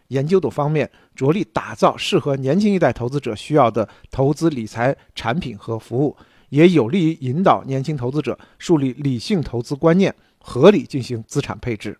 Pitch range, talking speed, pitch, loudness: 120-160 Hz, 285 characters per minute, 140 Hz, -19 LUFS